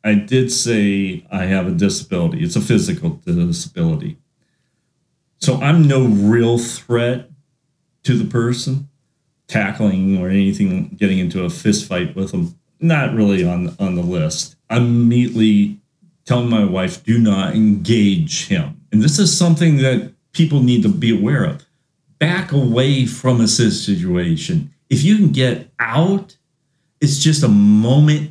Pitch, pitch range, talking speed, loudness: 145 Hz, 115-165 Hz, 145 wpm, -16 LUFS